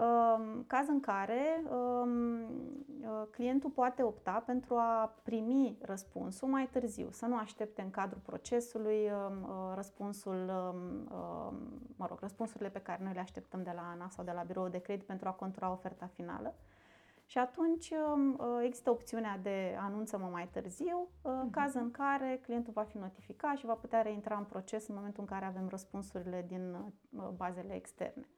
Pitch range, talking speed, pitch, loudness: 190-250 Hz, 150 wpm, 220 Hz, -38 LUFS